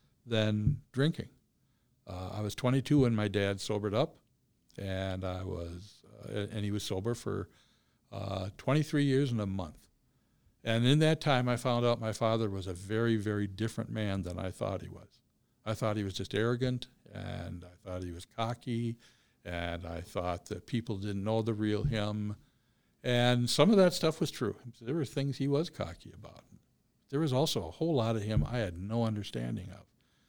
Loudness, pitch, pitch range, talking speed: -33 LUFS, 110 Hz, 100-125 Hz, 190 wpm